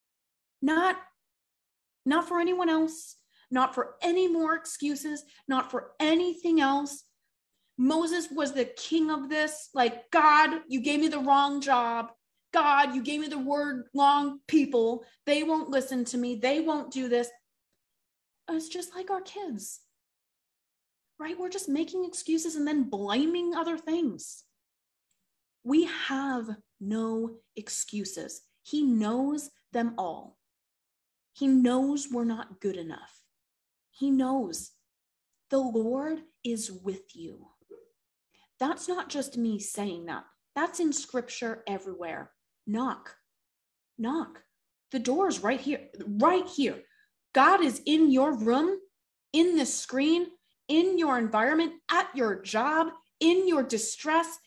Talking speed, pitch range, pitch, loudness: 130 wpm, 245-325 Hz, 285 Hz, -28 LUFS